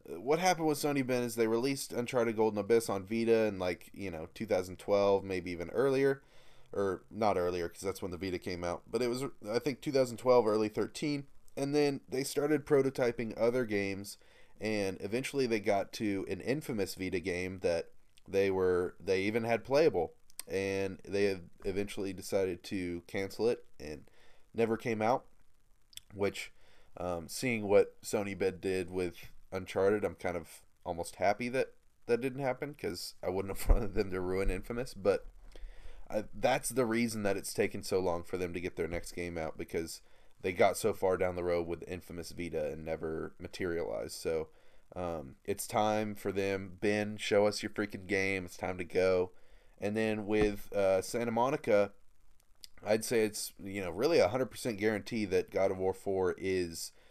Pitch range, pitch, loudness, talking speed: 95-120 Hz, 105 Hz, -34 LUFS, 180 wpm